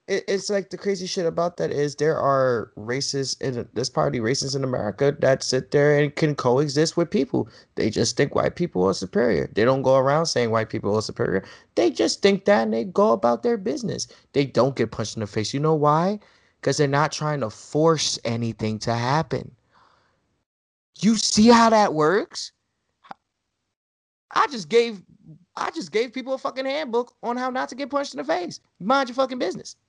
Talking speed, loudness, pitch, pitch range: 195 wpm, -22 LUFS, 155 Hz, 130-205 Hz